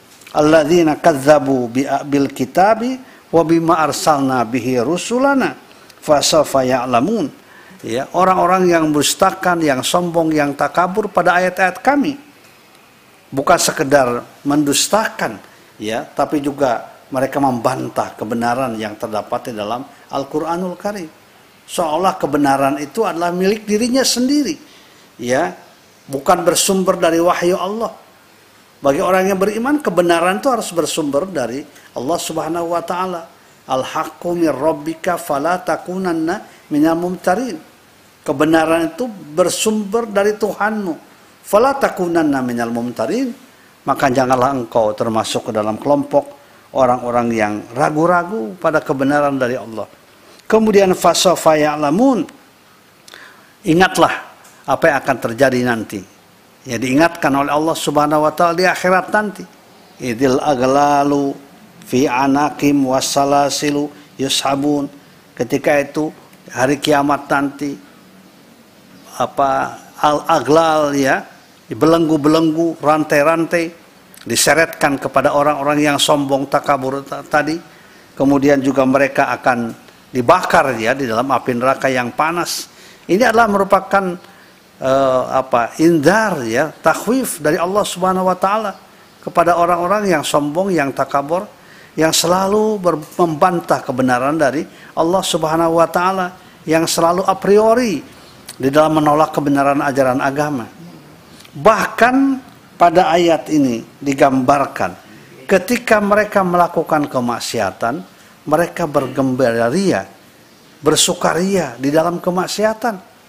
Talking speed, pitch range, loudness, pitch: 105 wpm, 140-185 Hz, -16 LUFS, 165 Hz